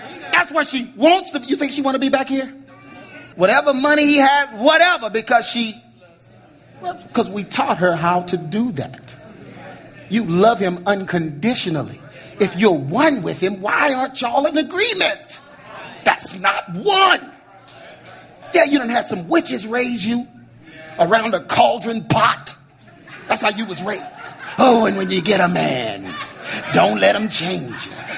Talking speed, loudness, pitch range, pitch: 160 wpm, -17 LUFS, 195-290 Hz, 235 Hz